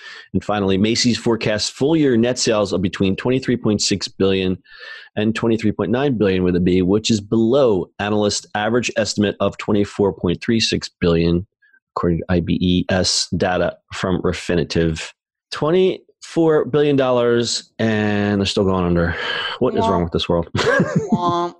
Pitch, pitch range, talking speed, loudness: 105 Hz, 90-120 Hz, 130 wpm, -18 LUFS